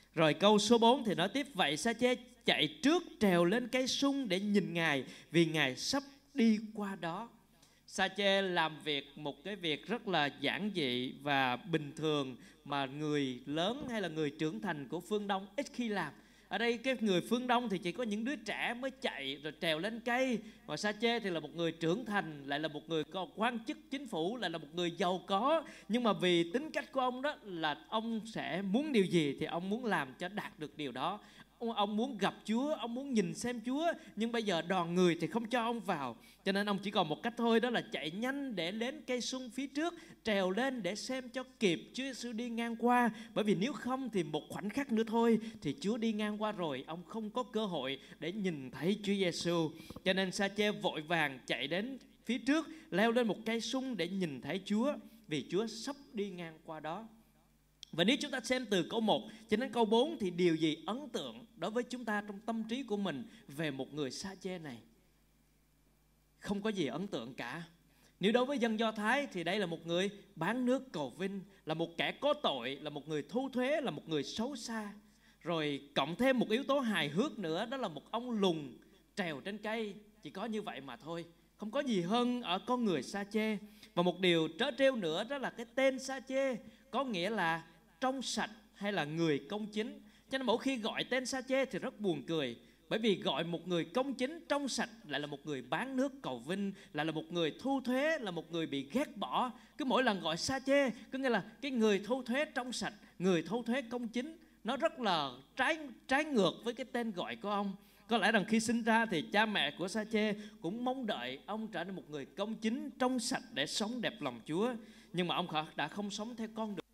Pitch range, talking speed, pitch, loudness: 170-245 Hz, 230 wpm, 210 Hz, -36 LUFS